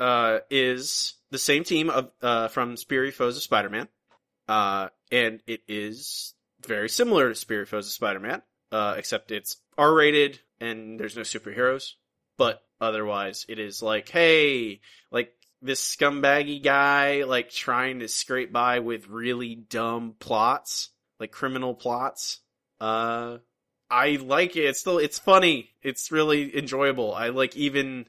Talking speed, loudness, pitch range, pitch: 150 wpm, -25 LUFS, 115-140 Hz, 125 Hz